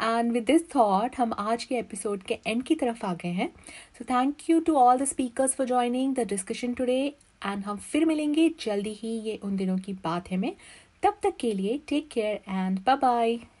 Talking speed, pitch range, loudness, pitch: 215 wpm, 210-265 Hz, -27 LUFS, 240 Hz